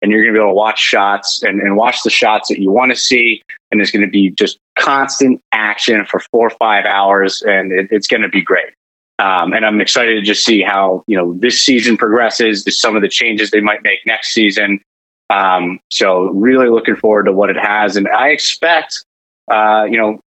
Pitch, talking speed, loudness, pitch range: 105 Hz, 215 wpm, -11 LUFS, 95-110 Hz